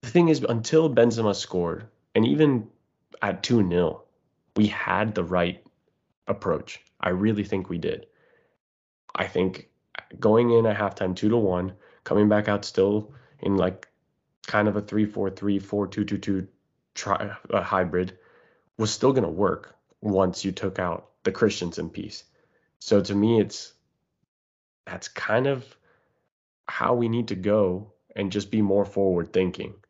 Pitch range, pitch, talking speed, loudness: 95-110 Hz, 100 Hz, 160 wpm, -25 LUFS